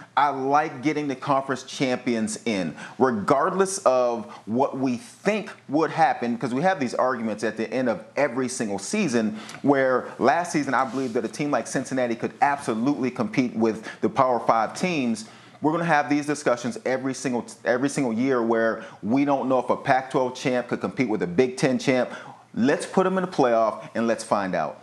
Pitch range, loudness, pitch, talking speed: 120-150 Hz, -24 LUFS, 130 Hz, 195 wpm